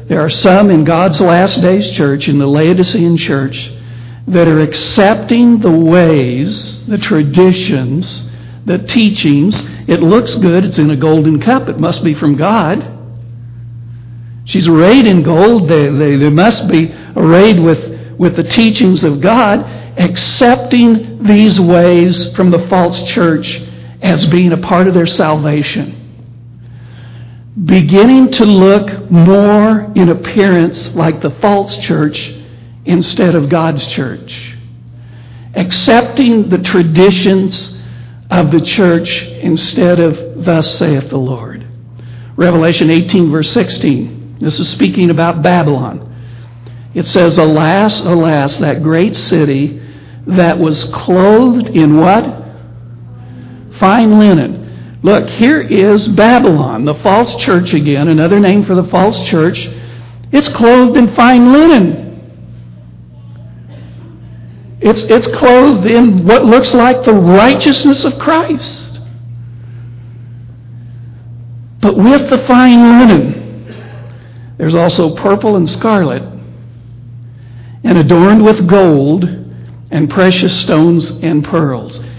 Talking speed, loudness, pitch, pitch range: 120 wpm, -9 LUFS, 165 Hz, 120-195 Hz